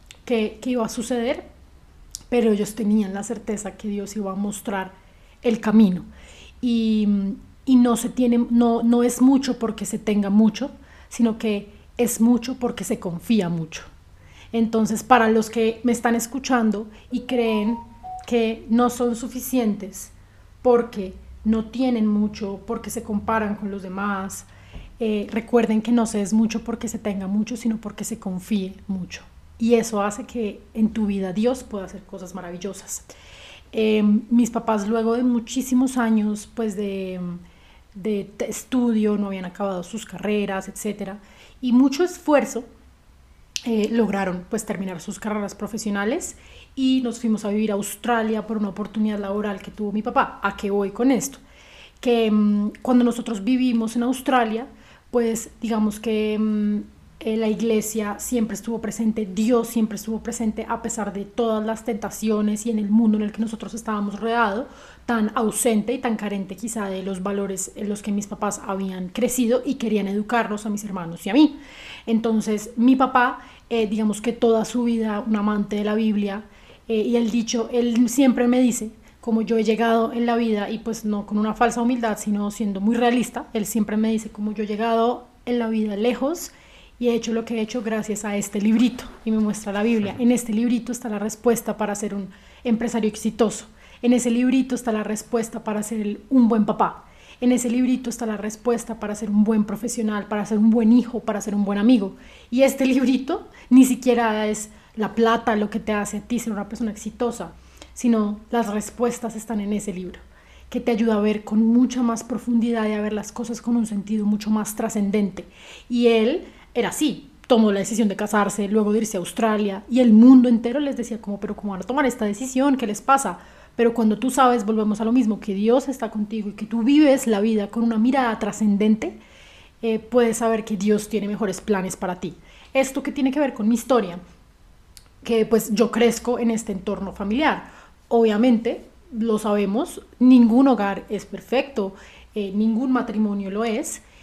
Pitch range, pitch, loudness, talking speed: 210-240 Hz, 220 Hz, -22 LUFS, 185 wpm